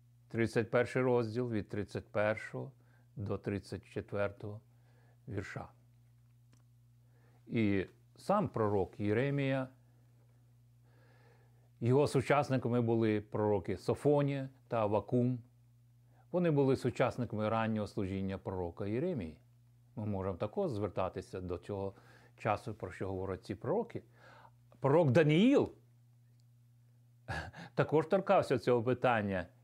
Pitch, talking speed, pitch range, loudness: 120 Hz, 85 wpm, 105-125 Hz, -34 LUFS